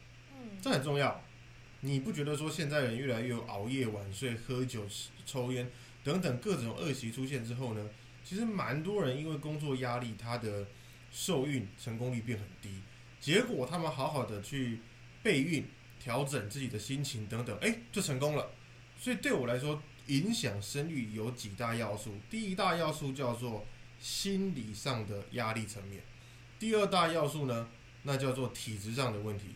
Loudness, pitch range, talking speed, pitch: -36 LUFS, 115-145 Hz, 250 characters per minute, 125 Hz